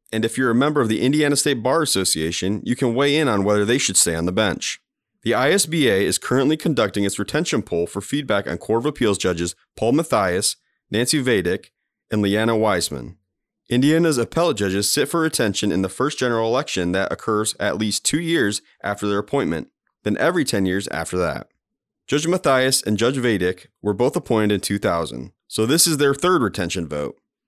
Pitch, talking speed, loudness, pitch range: 105 Hz, 190 wpm, -20 LUFS, 95-135 Hz